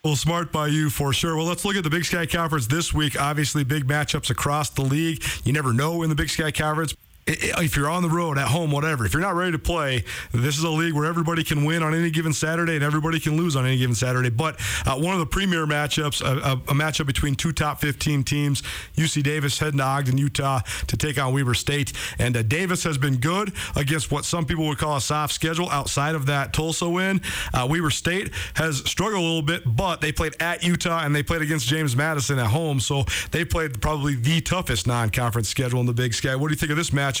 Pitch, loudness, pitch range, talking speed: 150 Hz, -23 LUFS, 135-165 Hz, 245 wpm